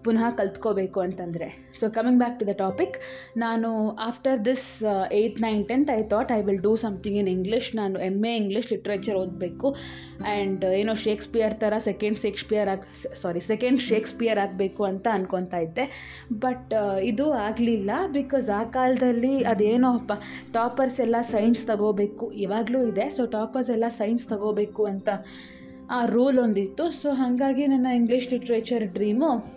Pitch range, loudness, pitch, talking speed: 205-240 Hz, -25 LUFS, 220 Hz, 145 wpm